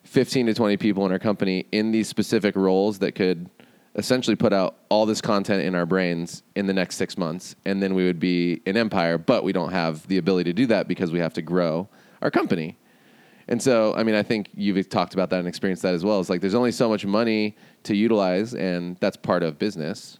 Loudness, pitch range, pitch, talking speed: -23 LUFS, 90-105 Hz, 95 Hz, 235 wpm